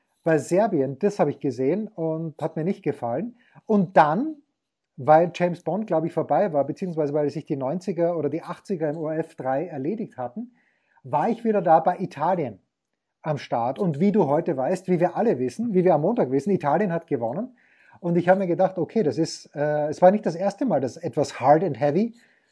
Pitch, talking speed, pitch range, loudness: 170 Hz, 210 wpm, 150-195 Hz, -24 LUFS